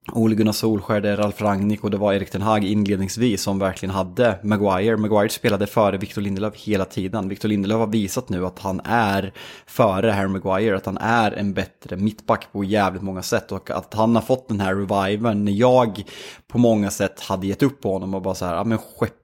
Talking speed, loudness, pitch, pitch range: 220 wpm, -21 LUFS, 105 Hz, 95-110 Hz